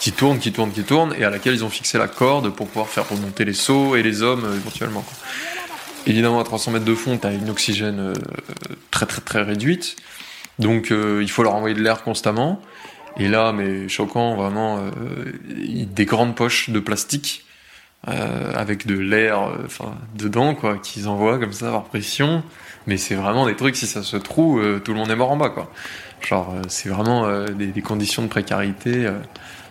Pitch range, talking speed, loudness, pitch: 105-120 Hz, 210 wpm, -21 LUFS, 110 Hz